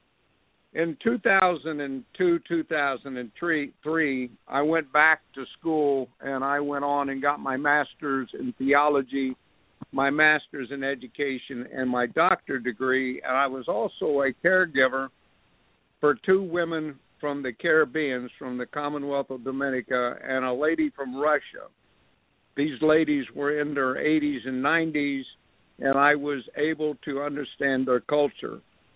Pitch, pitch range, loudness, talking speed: 140 Hz, 130-150 Hz, -26 LUFS, 135 wpm